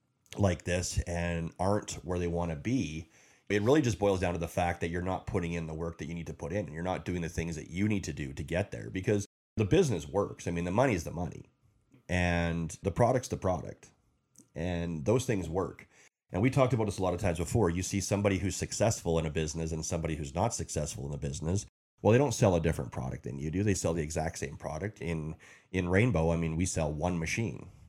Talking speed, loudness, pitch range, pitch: 245 wpm, -32 LUFS, 80-100 Hz, 90 Hz